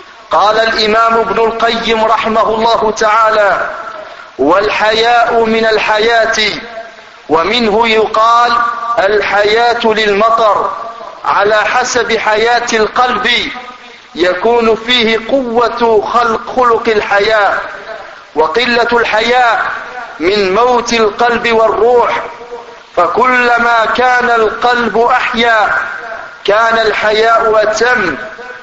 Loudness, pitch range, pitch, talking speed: -10 LUFS, 220-235 Hz, 225 Hz, 80 wpm